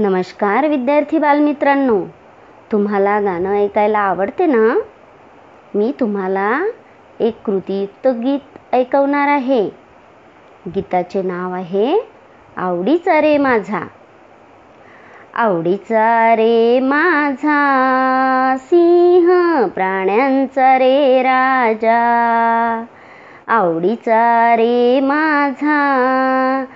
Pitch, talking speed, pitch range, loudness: 250 Hz, 70 wpm, 210-280 Hz, -15 LUFS